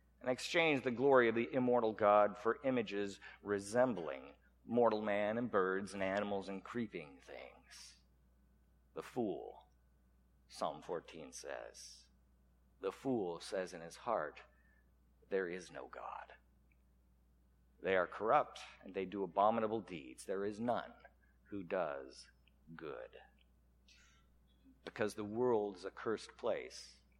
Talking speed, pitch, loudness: 125 wpm, 95 Hz, -38 LUFS